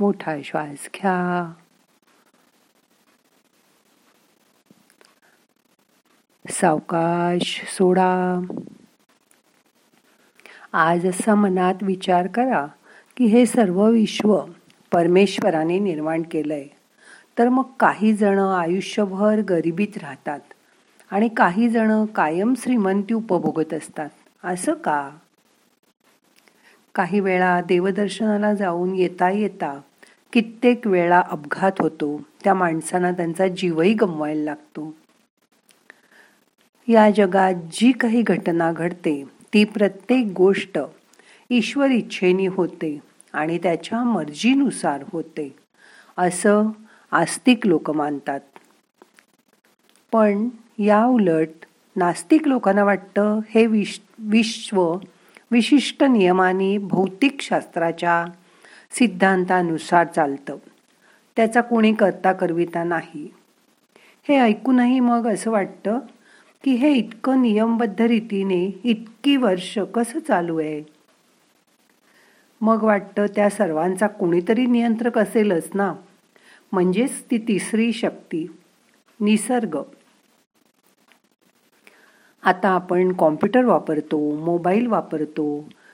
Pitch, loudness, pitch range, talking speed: 195 Hz, -20 LUFS, 175-225 Hz, 85 wpm